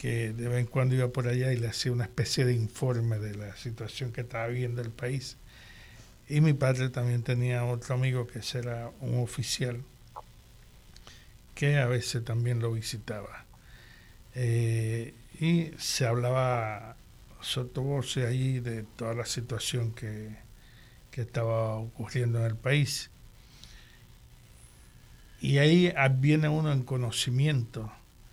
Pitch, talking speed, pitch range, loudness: 120 Hz, 140 wpm, 115-130 Hz, -30 LUFS